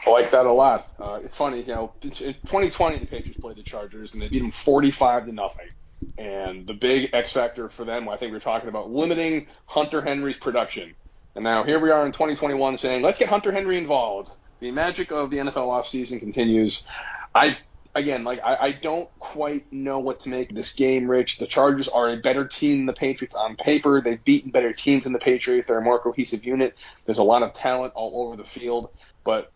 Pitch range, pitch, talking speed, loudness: 120-145 Hz, 130 Hz, 220 wpm, -23 LUFS